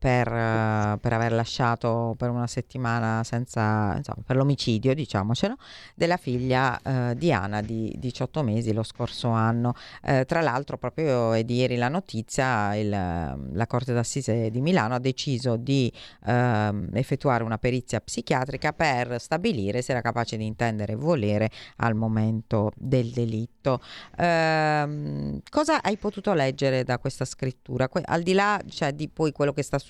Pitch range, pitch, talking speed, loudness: 115-140 Hz, 125 Hz, 155 wpm, -26 LUFS